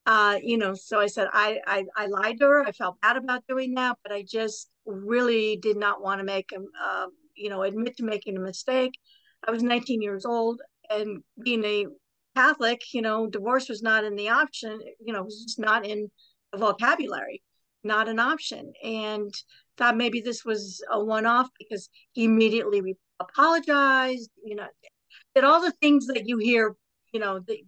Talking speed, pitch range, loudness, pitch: 190 wpm, 210-245 Hz, -25 LUFS, 220 Hz